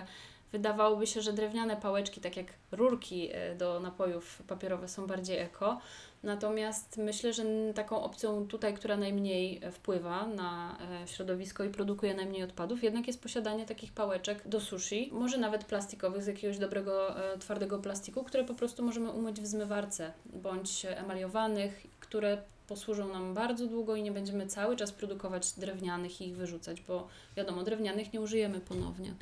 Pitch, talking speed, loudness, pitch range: 205 Hz, 150 wpm, -36 LUFS, 190-220 Hz